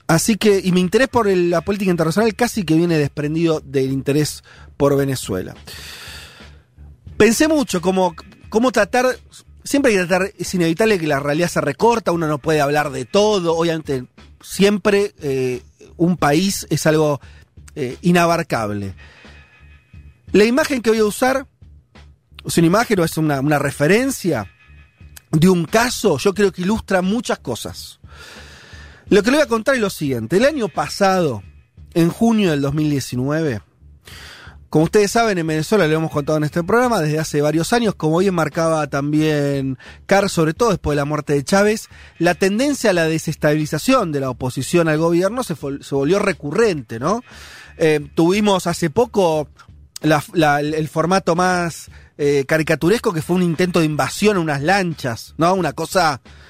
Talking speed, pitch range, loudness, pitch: 165 wpm, 145-200 Hz, -18 LUFS, 165 Hz